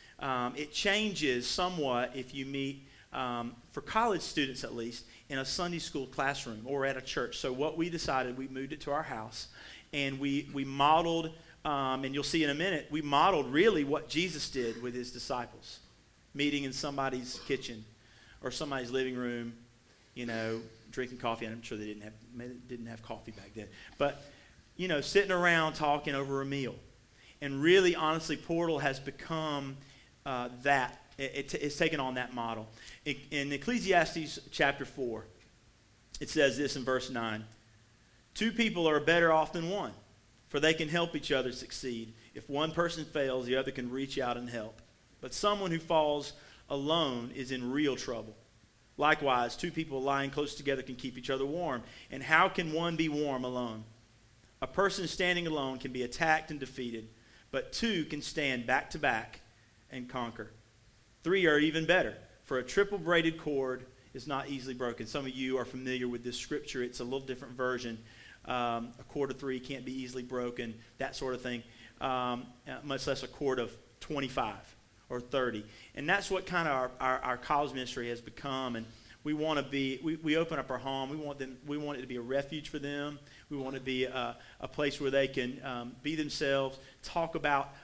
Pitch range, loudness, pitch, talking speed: 120-150 Hz, -33 LUFS, 135 Hz, 190 wpm